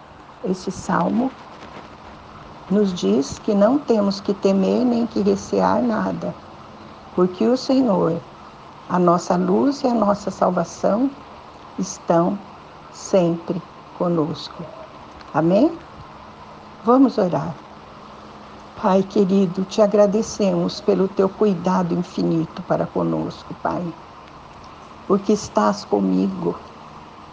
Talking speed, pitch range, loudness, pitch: 95 wpm, 160-210 Hz, -20 LUFS, 190 Hz